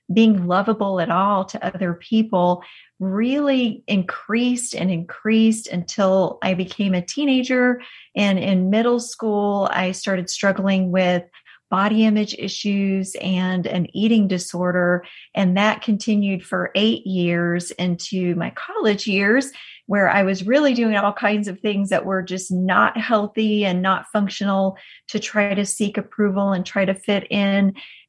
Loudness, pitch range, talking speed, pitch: -20 LUFS, 185-215 Hz, 145 wpm, 200 Hz